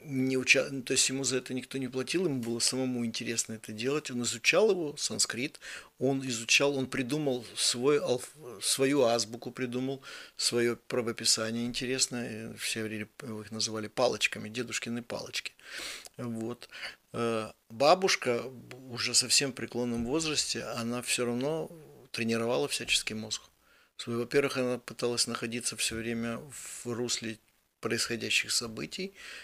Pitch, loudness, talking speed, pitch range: 120 Hz, -30 LUFS, 130 wpm, 115-130 Hz